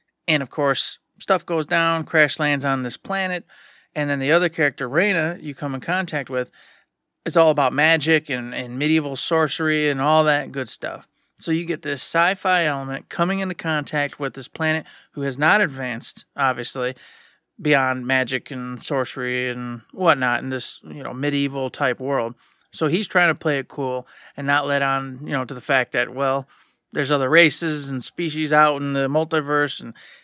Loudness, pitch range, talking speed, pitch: -21 LUFS, 135-160 Hz, 185 wpm, 145 Hz